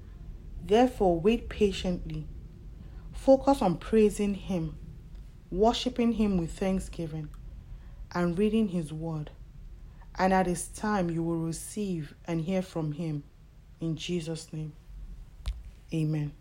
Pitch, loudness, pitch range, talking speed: 175 Hz, -29 LUFS, 160-205 Hz, 110 wpm